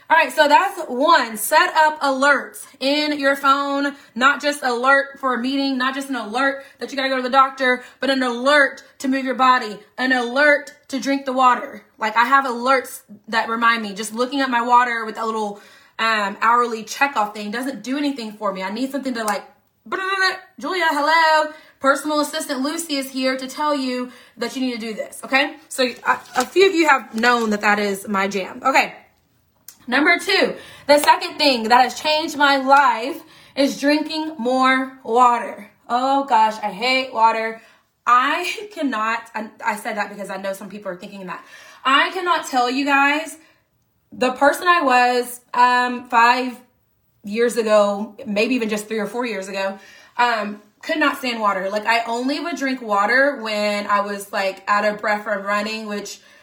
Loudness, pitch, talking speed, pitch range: -19 LUFS, 255 Hz, 185 wpm, 220-280 Hz